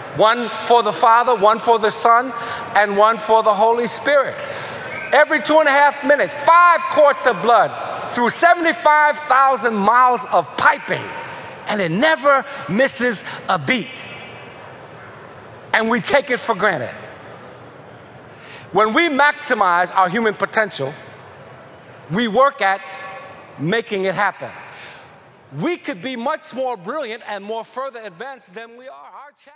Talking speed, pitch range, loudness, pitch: 140 wpm, 210-280 Hz, -16 LUFS, 235 Hz